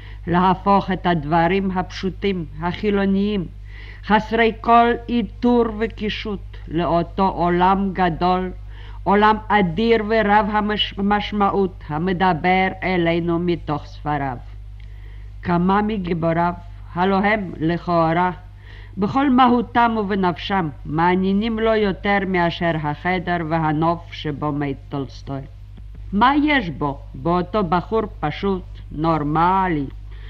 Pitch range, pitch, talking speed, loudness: 150-200 Hz, 180 Hz, 90 wpm, -20 LUFS